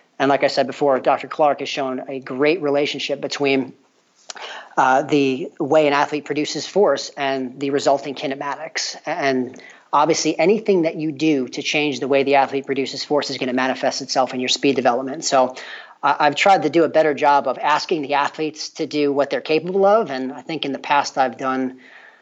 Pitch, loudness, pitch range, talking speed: 140 Hz, -19 LUFS, 135-150 Hz, 200 wpm